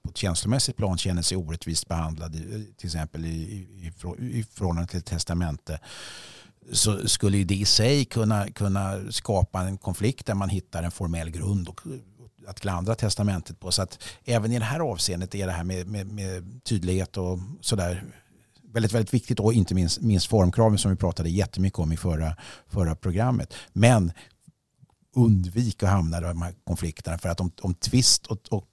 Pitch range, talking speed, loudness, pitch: 90-110 Hz, 180 wpm, -26 LUFS, 95 Hz